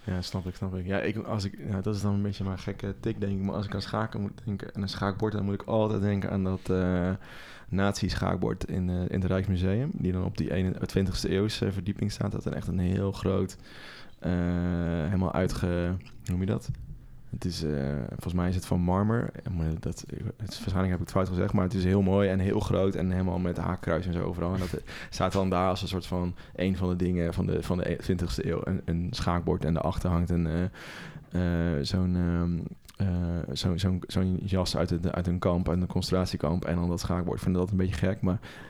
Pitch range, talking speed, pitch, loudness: 90-100 Hz, 235 wpm, 95 Hz, -29 LUFS